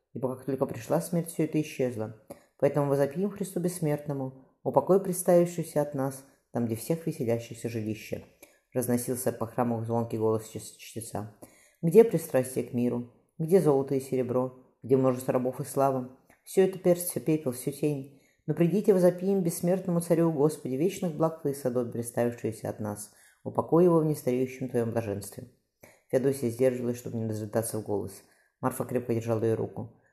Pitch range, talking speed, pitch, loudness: 120-160 Hz, 155 wpm, 130 Hz, -29 LUFS